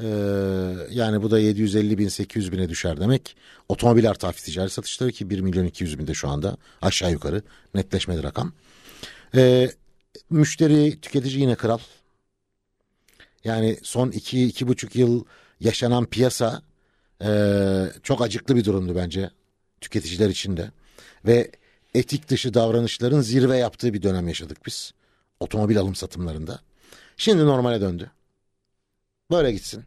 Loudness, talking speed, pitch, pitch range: -23 LUFS, 130 wpm, 105 Hz, 95-120 Hz